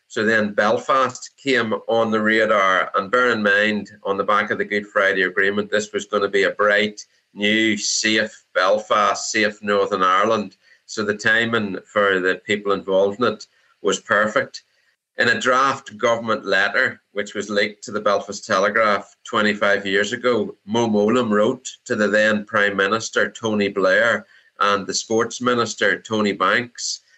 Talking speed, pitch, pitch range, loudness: 165 wpm, 105 Hz, 100-110 Hz, -19 LUFS